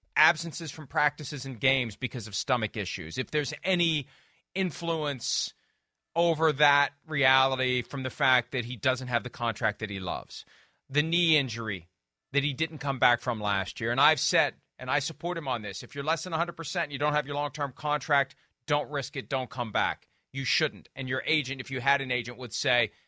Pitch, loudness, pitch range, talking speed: 135 Hz, -28 LUFS, 125-150 Hz, 205 wpm